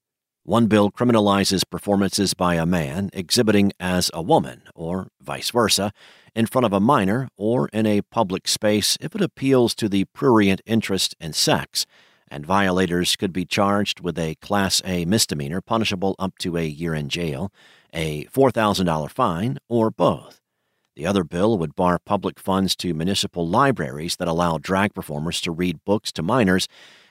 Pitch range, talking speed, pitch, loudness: 90-105 Hz, 165 wpm, 95 Hz, -21 LUFS